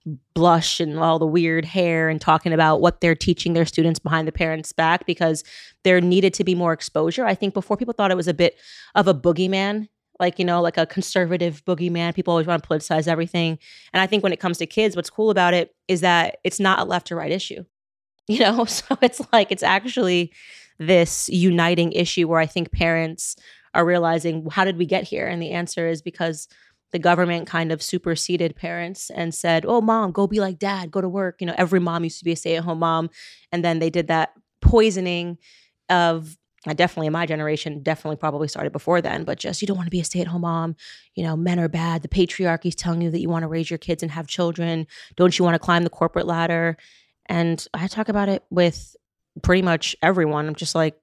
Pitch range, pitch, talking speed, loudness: 165-185 Hz, 170 Hz, 230 wpm, -21 LUFS